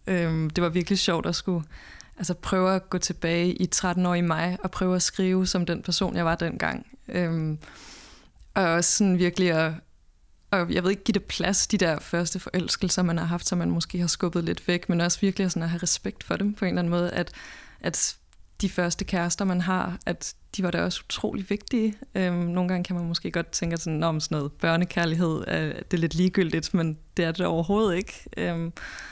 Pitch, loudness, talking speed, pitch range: 180 Hz, -26 LUFS, 220 wpm, 170-185 Hz